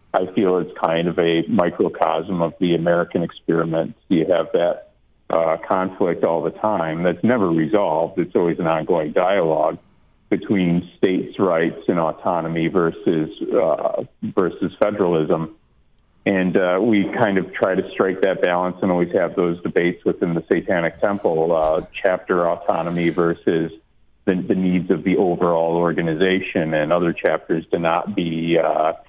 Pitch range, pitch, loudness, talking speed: 80-90 Hz, 85 Hz, -20 LUFS, 150 wpm